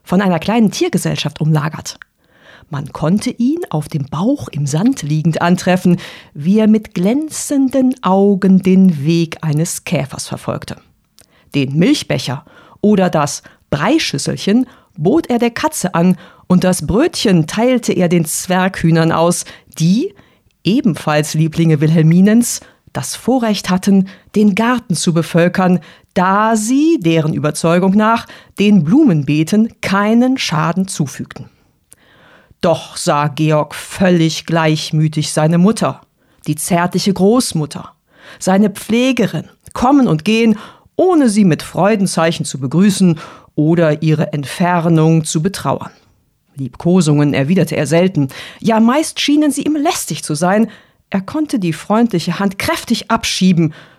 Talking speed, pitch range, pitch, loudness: 120 wpm, 160-220 Hz, 180 Hz, -14 LUFS